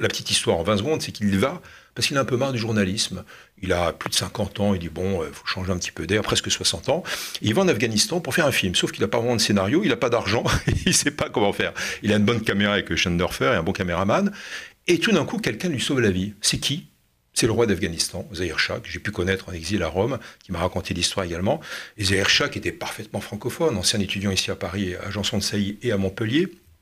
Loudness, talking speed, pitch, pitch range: -23 LUFS, 270 wpm, 100 Hz, 95-110 Hz